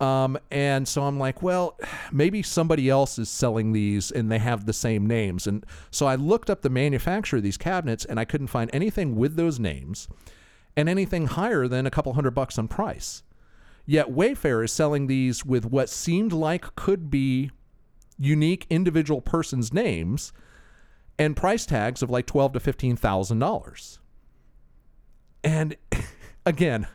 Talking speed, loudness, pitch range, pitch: 160 wpm, -25 LUFS, 115-155 Hz, 135 Hz